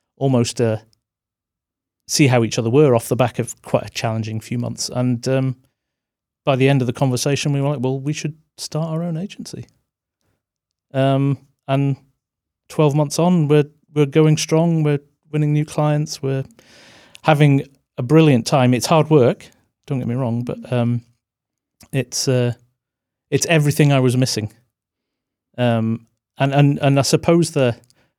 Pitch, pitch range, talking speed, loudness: 135 Hz, 120-150 Hz, 160 wpm, -18 LUFS